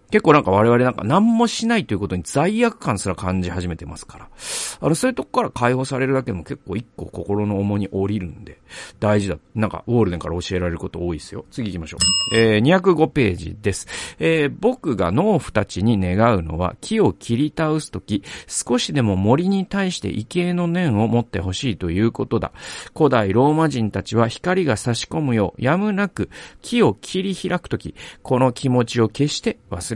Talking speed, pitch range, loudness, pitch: 390 characters per minute, 95-155 Hz, -20 LUFS, 115 Hz